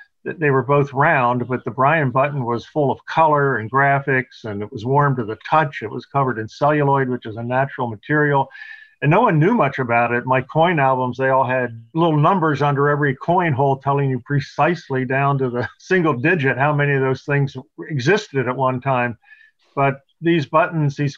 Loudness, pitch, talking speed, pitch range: -19 LUFS, 140 Hz, 200 wpm, 130-150 Hz